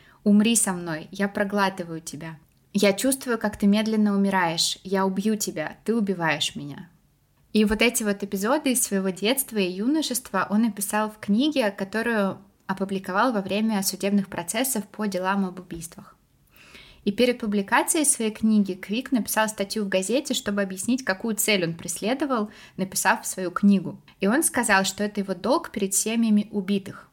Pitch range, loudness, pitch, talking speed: 190-225 Hz, -24 LUFS, 205 Hz, 155 wpm